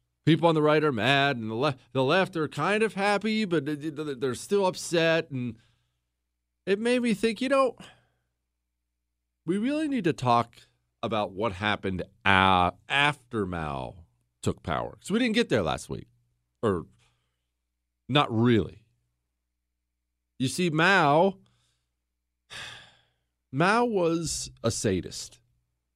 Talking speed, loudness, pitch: 130 wpm, -26 LUFS, 115 Hz